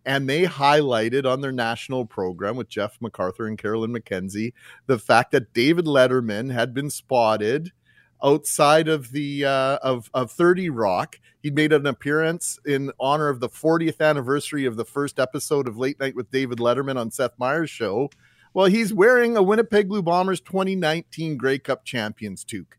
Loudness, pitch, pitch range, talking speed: -22 LUFS, 140 Hz, 125-155 Hz, 170 wpm